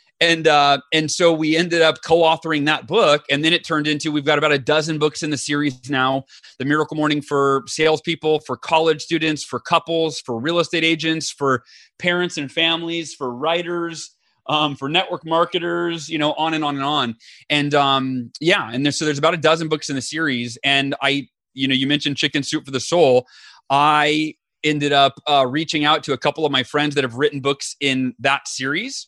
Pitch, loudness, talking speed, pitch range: 150 Hz, -19 LUFS, 205 wpm, 140-160 Hz